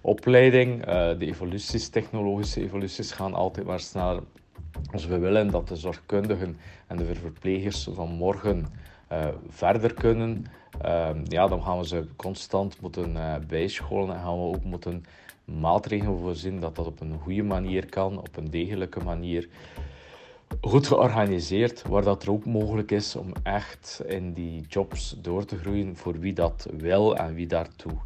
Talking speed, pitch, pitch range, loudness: 155 wpm, 95 Hz, 85-100 Hz, -27 LUFS